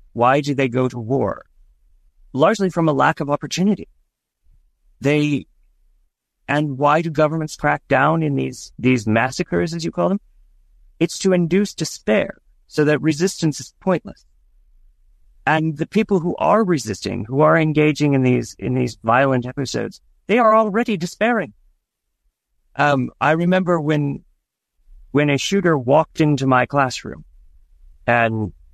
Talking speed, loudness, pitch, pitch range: 140 wpm, -19 LUFS, 140 Hz, 100-160 Hz